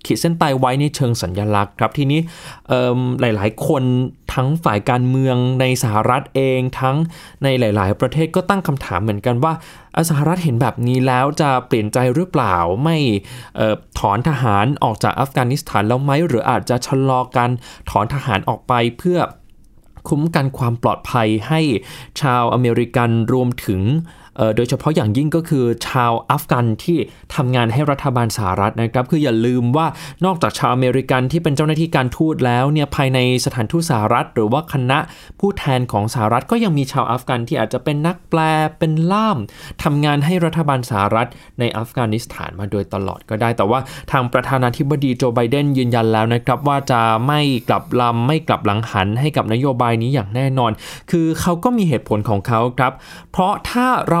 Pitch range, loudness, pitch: 120-150 Hz, -17 LUFS, 130 Hz